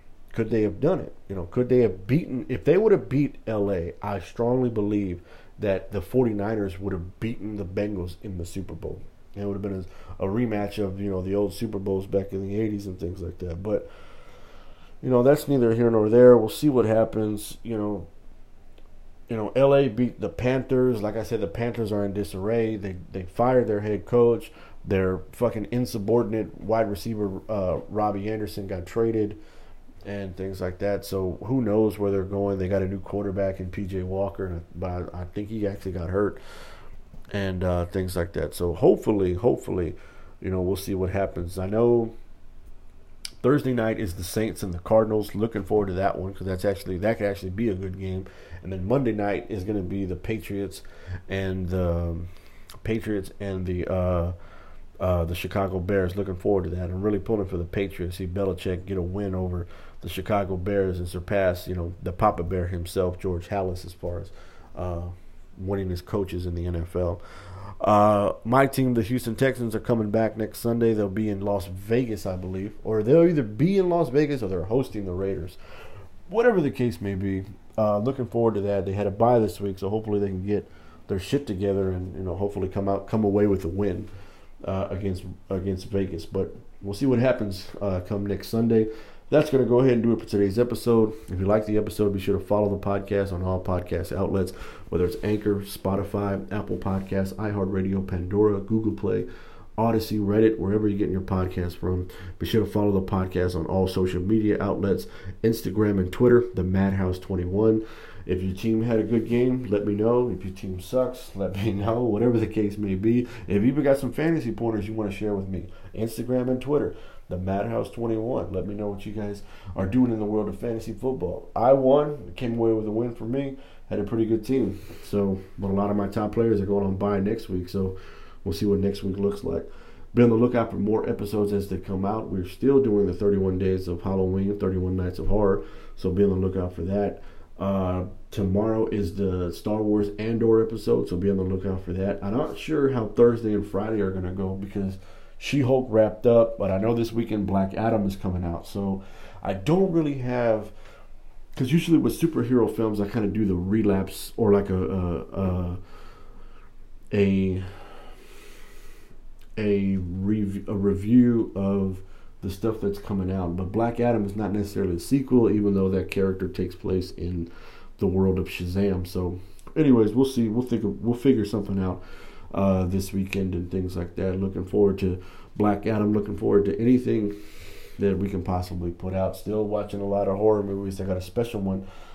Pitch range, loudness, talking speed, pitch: 95-110 Hz, -25 LUFS, 205 wpm, 100 Hz